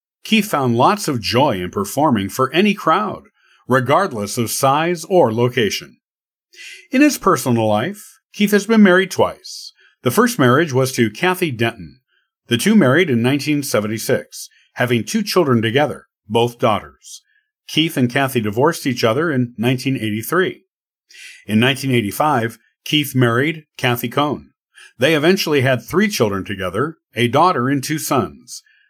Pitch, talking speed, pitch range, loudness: 135 Hz, 140 wpm, 120-180 Hz, -17 LUFS